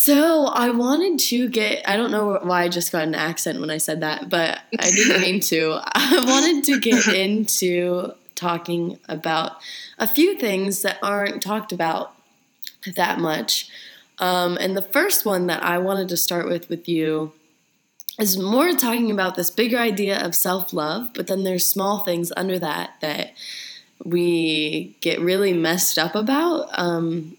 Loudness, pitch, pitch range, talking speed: -20 LUFS, 185 Hz, 170-220 Hz, 170 wpm